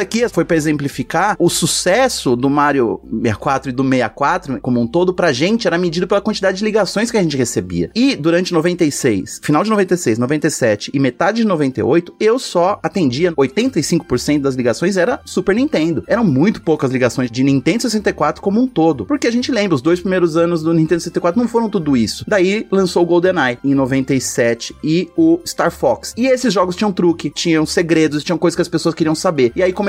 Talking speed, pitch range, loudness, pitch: 195 wpm, 145-200 Hz, -16 LUFS, 170 Hz